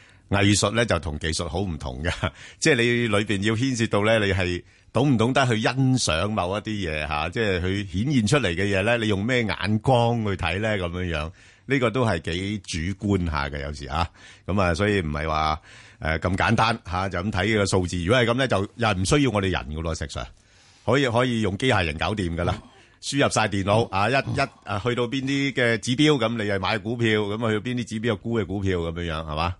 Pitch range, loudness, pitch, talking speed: 90-115 Hz, -23 LUFS, 100 Hz, 320 characters per minute